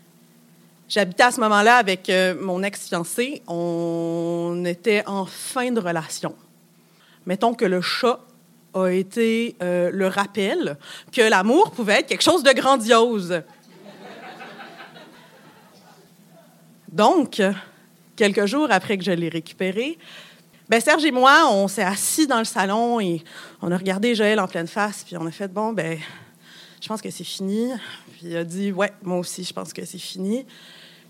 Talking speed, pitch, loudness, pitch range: 155 wpm, 195 Hz, -21 LUFS, 180-230 Hz